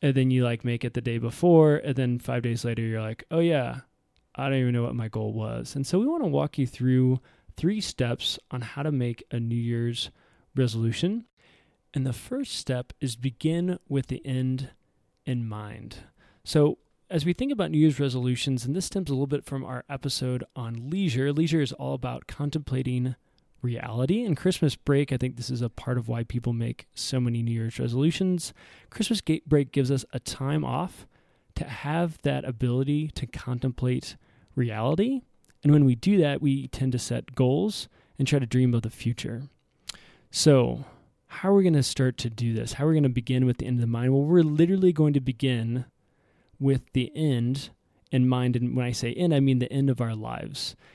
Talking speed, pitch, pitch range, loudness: 205 wpm, 130 Hz, 120-150 Hz, -26 LUFS